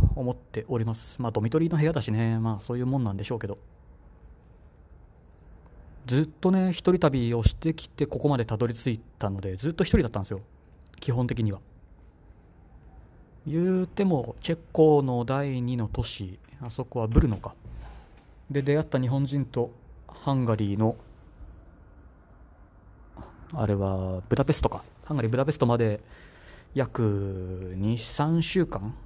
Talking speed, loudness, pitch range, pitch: 285 characters per minute, -27 LUFS, 95-135 Hz, 115 Hz